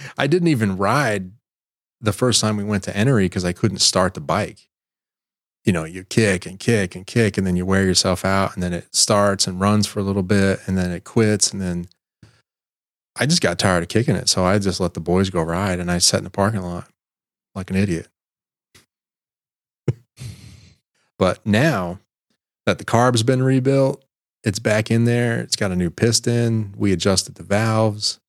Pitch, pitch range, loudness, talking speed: 100 Hz, 95-115 Hz, -19 LUFS, 195 wpm